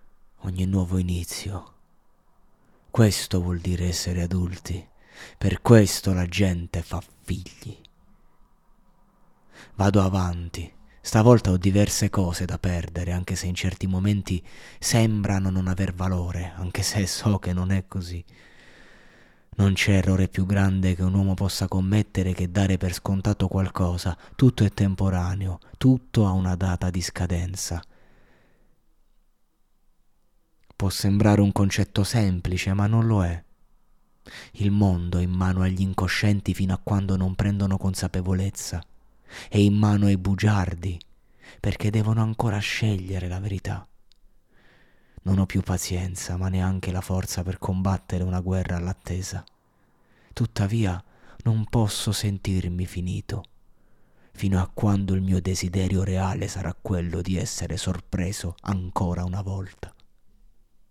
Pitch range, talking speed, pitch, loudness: 90-100 Hz, 125 wpm, 95 Hz, -24 LUFS